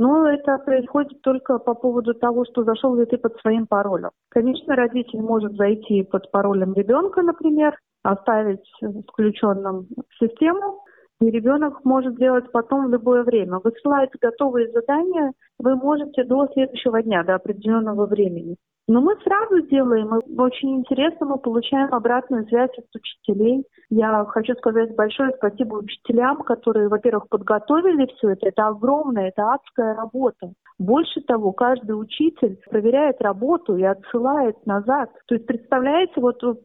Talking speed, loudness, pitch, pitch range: 140 wpm, -20 LUFS, 245 Hz, 220-270 Hz